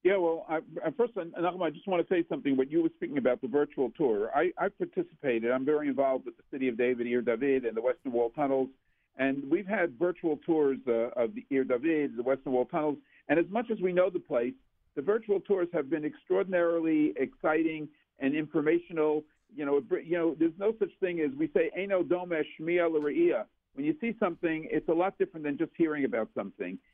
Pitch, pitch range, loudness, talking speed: 160 Hz, 140-185 Hz, -30 LUFS, 205 wpm